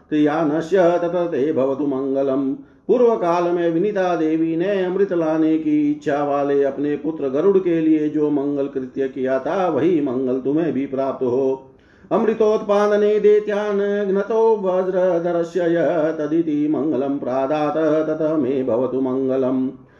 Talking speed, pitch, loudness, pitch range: 115 wpm, 155 Hz, -19 LUFS, 135-185 Hz